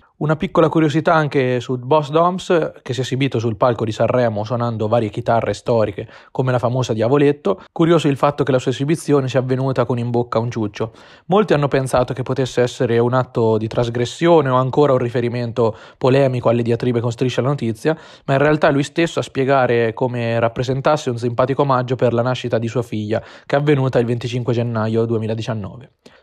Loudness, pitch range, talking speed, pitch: -18 LUFS, 120-140 Hz, 190 wpm, 125 Hz